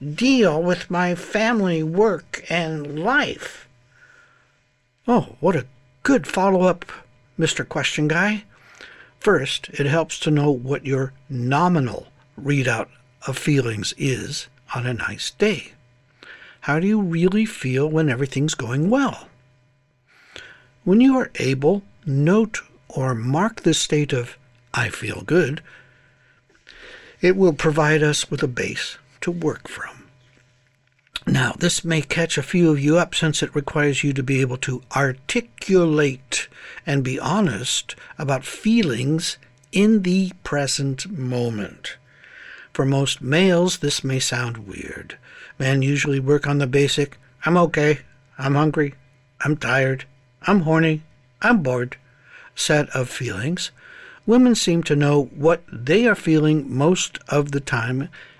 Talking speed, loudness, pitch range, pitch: 130 wpm, -21 LUFS, 130-175 Hz, 150 Hz